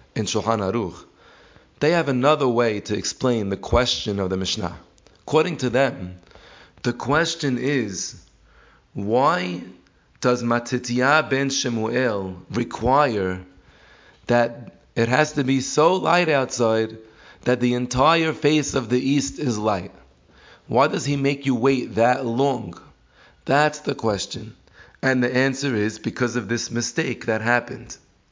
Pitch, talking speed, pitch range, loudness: 120 Hz, 135 wpm, 105-135 Hz, -22 LUFS